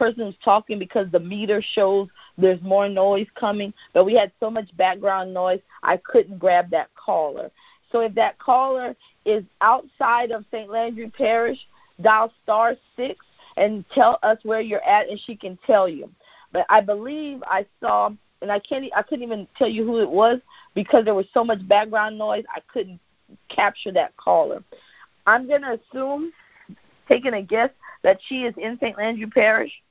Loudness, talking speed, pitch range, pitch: -21 LUFS, 180 wpm, 200-240 Hz, 220 Hz